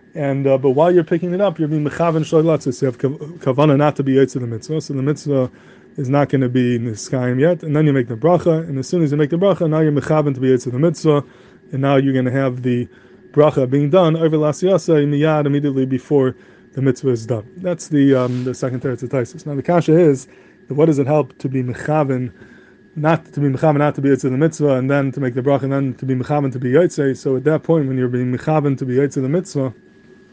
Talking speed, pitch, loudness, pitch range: 260 wpm, 140 Hz, -17 LUFS, 130-155 Hz